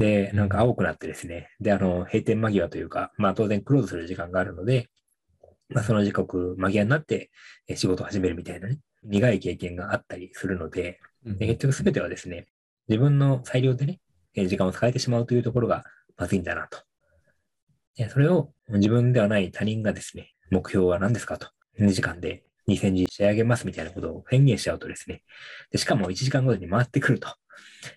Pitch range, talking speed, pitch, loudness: 95-120 Hz, 390 characters per minute, 105 Hz, -25 LUFS